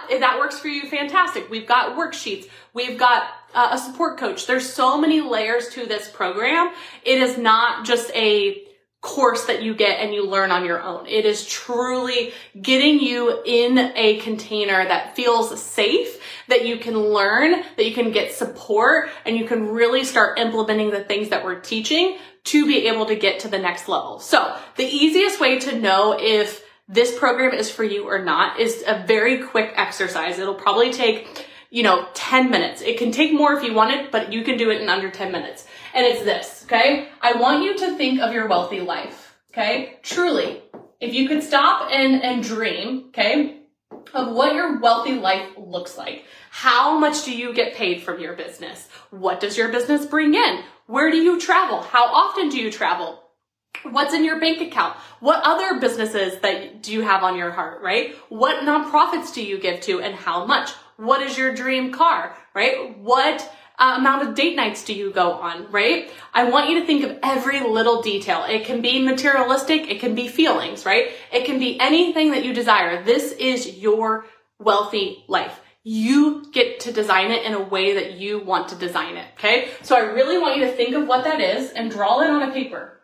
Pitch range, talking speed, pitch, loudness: 215-290 Hz, 200 wpm, 245 Hz, -19 LUFS